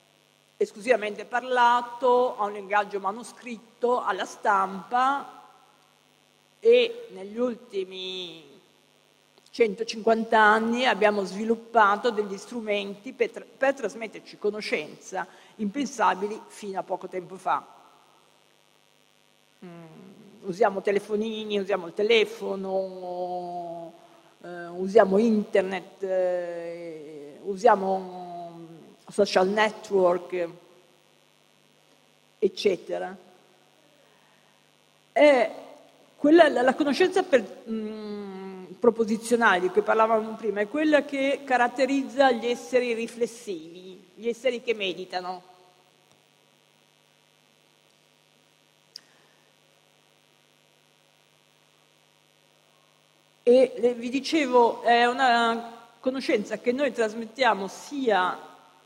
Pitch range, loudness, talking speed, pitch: 190-245 Hz, -25 LUFS, 75 wpm, 215 Hz